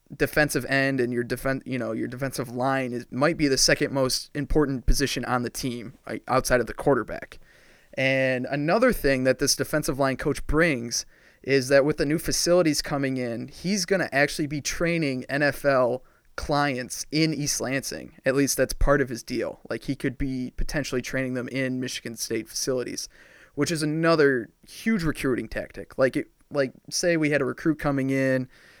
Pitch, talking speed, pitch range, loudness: 135 Hz, 185 wpm, 130-150 Hz, -25 LUFS